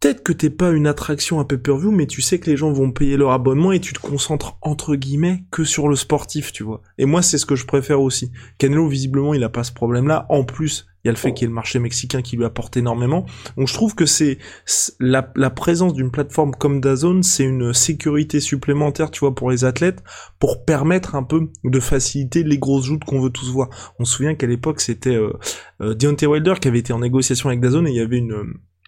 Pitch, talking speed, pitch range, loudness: 140 Hz, 245 wpm, 125-155 Hz, -18 LUFS